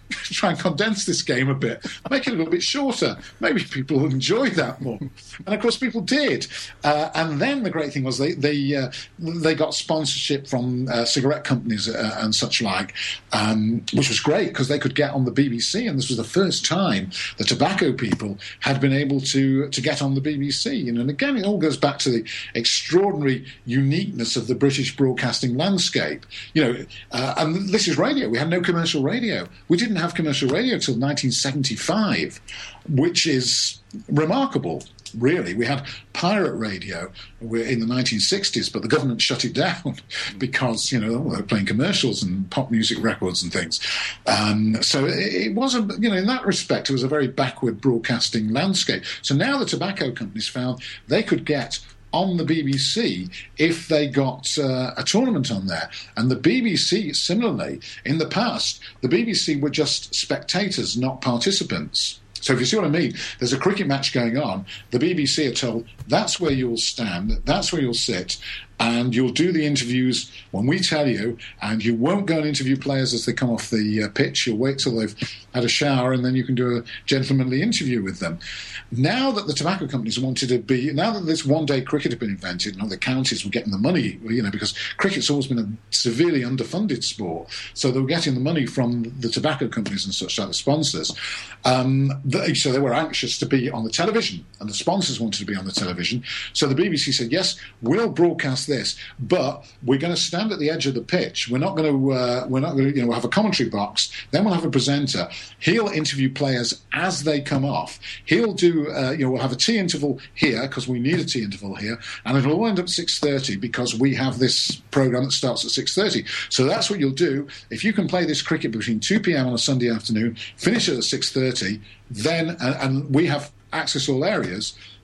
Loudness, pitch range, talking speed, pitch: -22 LUFS, 120-160 Hz, 210 wpm, 135 Hz